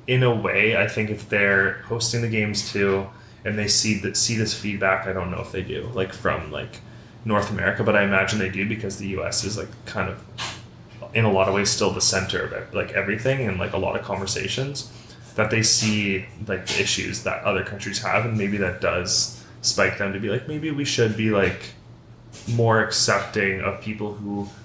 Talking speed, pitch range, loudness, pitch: 215 wpm, 100-115 Hz, -22 LUFS, 105 Hz